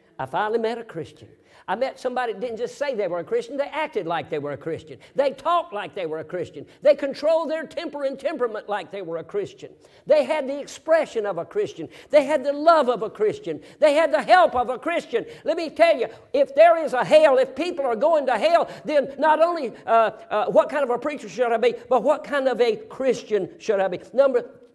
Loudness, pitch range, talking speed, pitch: -22 LUFS, 235-310 Hz, 245 wpm, 275 Hz